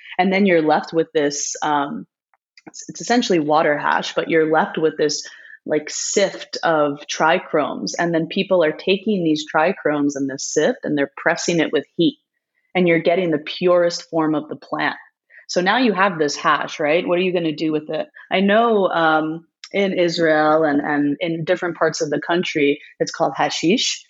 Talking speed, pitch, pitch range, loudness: 190 wpm, 165 Hz, 155-185 Hz, -19 LUFS